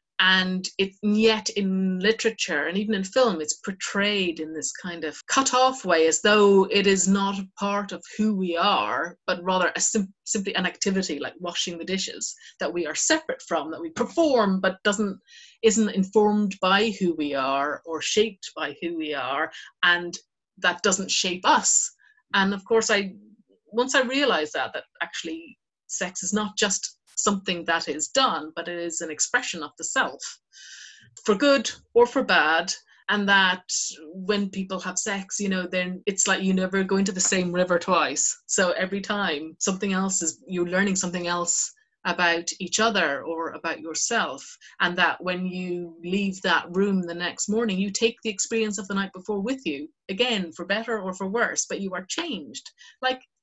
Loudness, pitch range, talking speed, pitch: -24 LUFS, 175-215 Hz, 185 wpm, 195 Hz